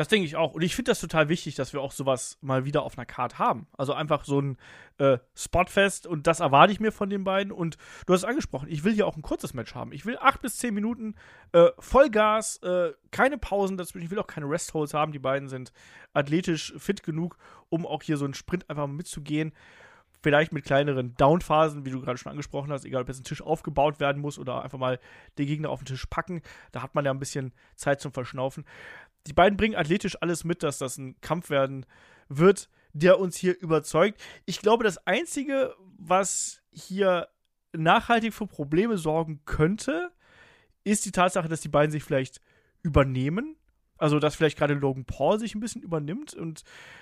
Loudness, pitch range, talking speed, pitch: -26 LUFS, 140-195 Hz, 205 wpm, 160 Hz